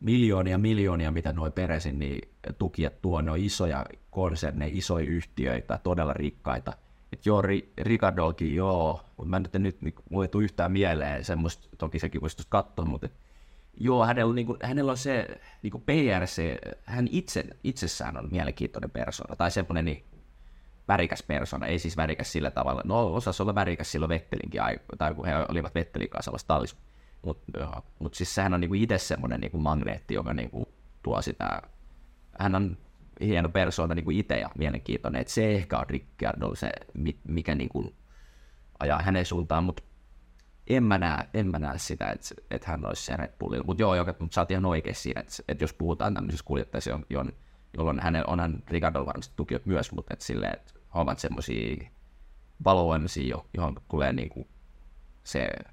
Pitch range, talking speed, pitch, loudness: 70-95 Hz, 175 wpm, 80 Hz, -30 LUFS